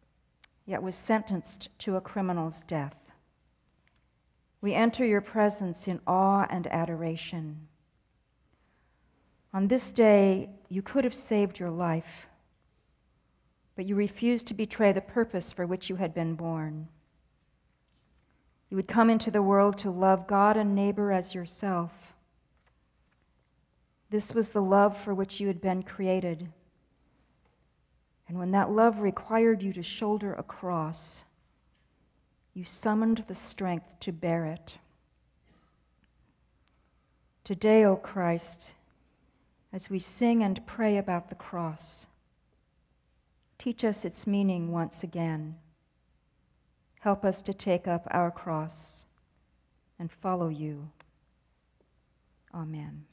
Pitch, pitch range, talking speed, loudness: 180 Hz, 155-200 Hz, 120 wpm, -29 LUFS